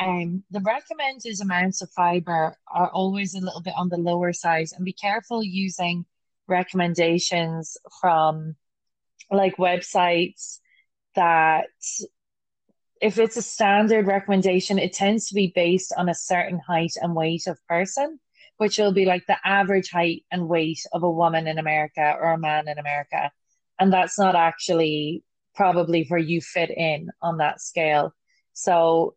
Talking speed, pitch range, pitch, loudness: 150 wpm, 165-195 Hz, 175 Hz, -23 LUFS